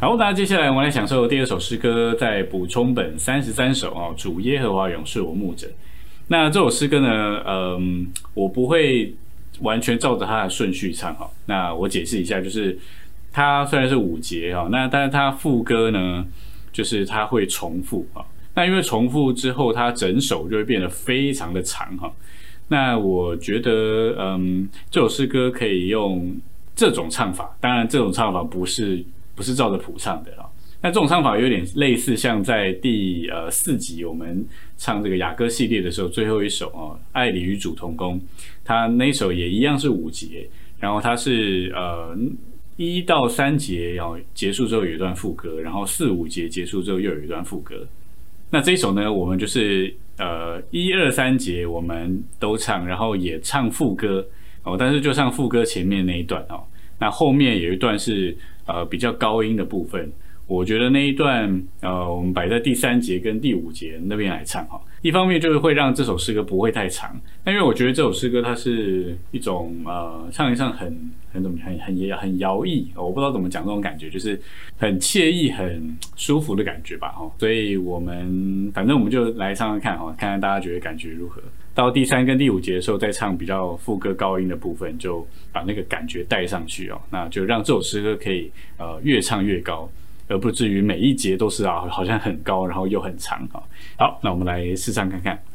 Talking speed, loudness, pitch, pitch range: 290 characters per minute, -21 LUFS, 100 Hz, 90-120 Hz